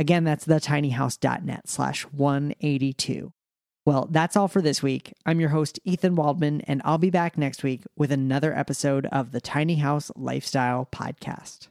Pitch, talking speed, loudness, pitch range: 145 Hz, 160 wpm, -25 LUFS, 135-160 Hz